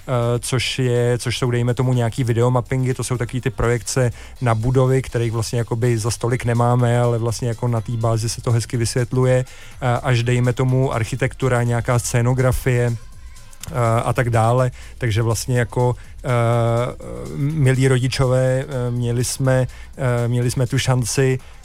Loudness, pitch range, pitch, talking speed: -19 LUFS, 120-130 Hz, 120 Hz, 155 wpm